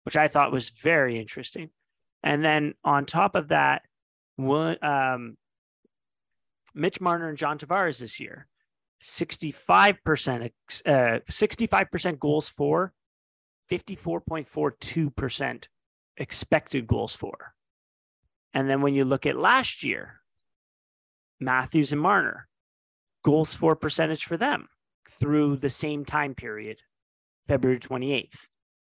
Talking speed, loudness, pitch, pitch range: 110 wpm, -25 LUFS, 140 Hz, 115-155 Hz